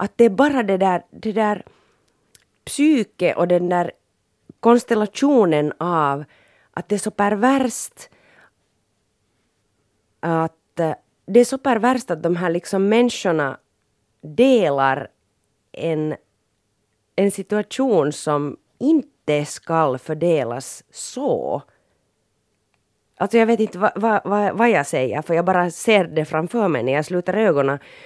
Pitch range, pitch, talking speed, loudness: 135-215 Hz, 170 Hz, 125 wpm, -20 LUFS